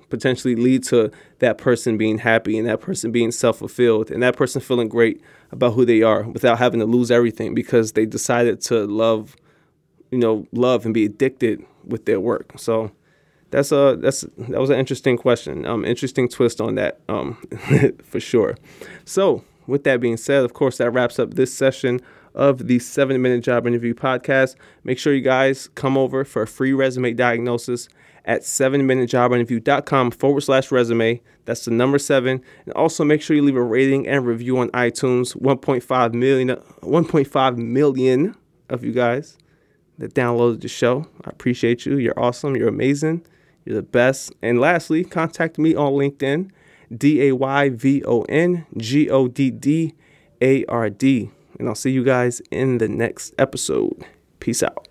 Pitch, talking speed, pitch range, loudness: 130 Hz, 160 wpm, 120-140 Hz, -19 LUFS